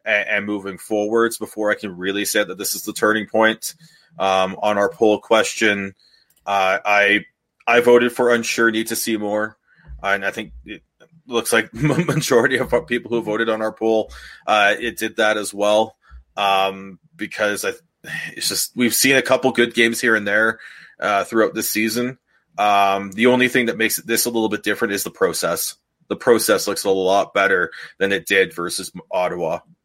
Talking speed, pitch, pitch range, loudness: 185 wpm, 110 Hz, 100-120 Hz, -19 LUFS